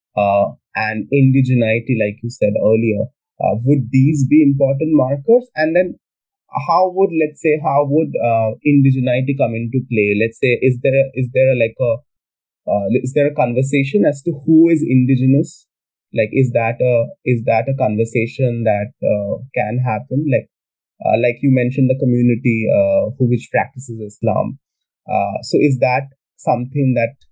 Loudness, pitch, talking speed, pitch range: -16 LUFS, 130 Hz, 165 wpm, 115-145 Hz